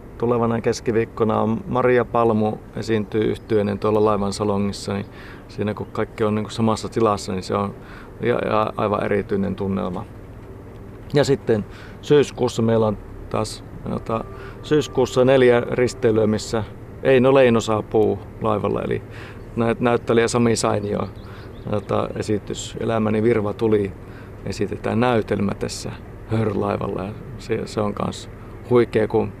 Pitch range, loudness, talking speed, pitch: 100-115 Hz, -21 LUFS, 120 wpm, 110 Hz